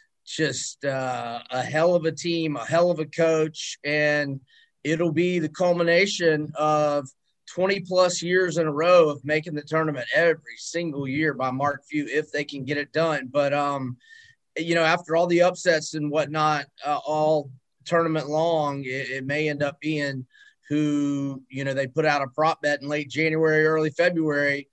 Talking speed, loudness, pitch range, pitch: 180 wpm, -24 LUFS, 145-165 Hz, 155 Hz